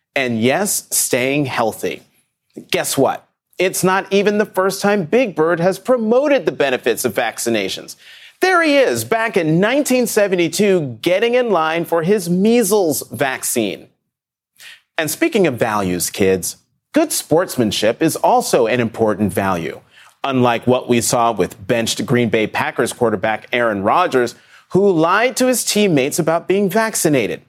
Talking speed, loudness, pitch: 140 wpm, -16 LUFS, 180 Hz